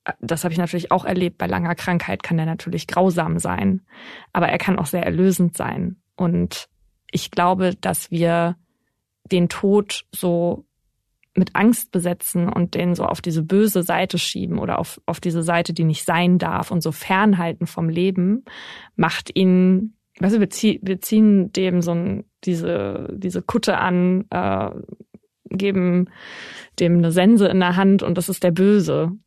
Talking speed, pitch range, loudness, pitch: 160 wpm, 175-195 Hz, -20 LUFS, 180 Hz